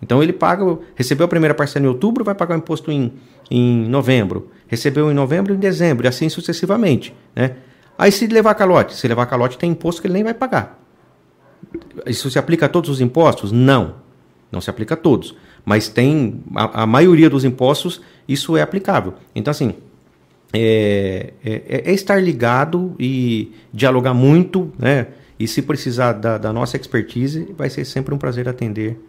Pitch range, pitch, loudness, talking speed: 120-170 Hz, 135 Hz, -17 LUFS, 175 wpm